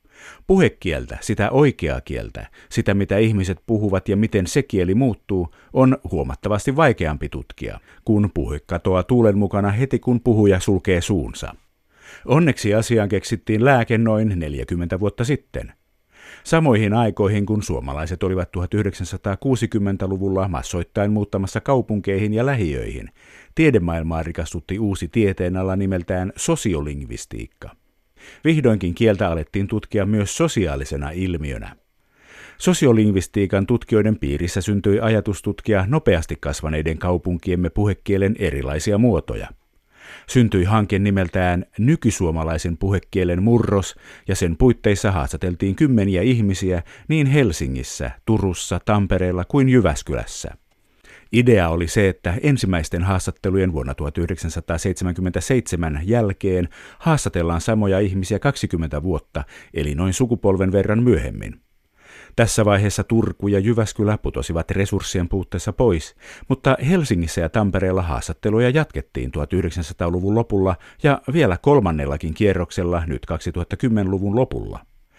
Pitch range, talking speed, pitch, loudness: 85-110 Hz, 105 wpm, 100 Hz, -20 LUFS